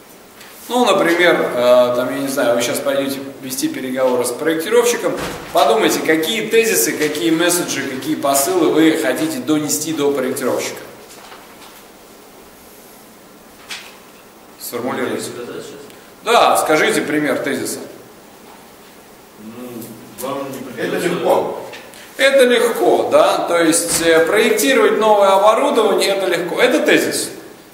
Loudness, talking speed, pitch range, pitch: -15 LUFS, 95 wpm, 135-215 Hz, 160 Hz